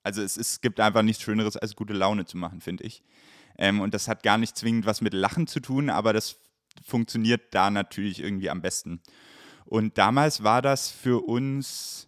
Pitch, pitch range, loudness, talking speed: 110 Hz, 100-120 Hz, -26 LUFS, 205 wpm